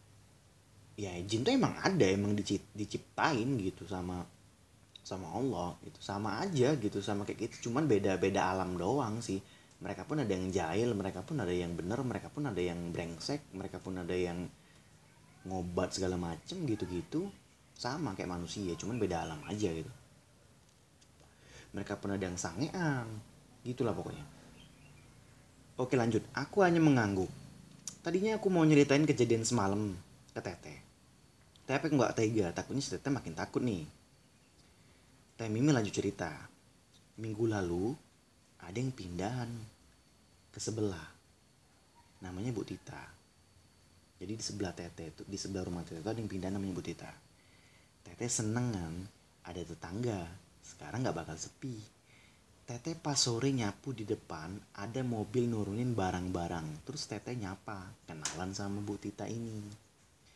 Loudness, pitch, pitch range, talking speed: -36 LUFS, 100 Hz, 90-120 Hz, 140 wpm